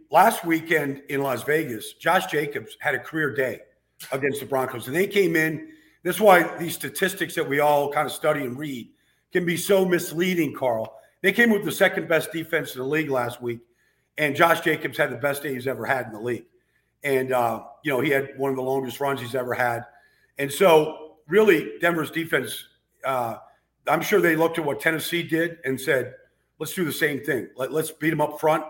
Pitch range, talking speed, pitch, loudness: 135-165 Hz, 205 wpm, 150 Hz, -23 LUFS